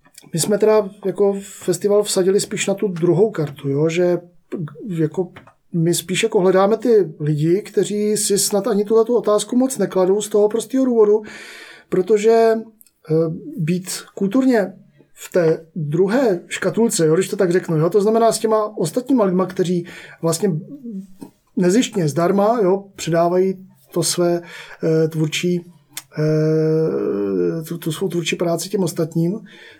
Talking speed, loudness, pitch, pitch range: 135 wpm, -18 LUFS, 185 Hz, 170-210 Hz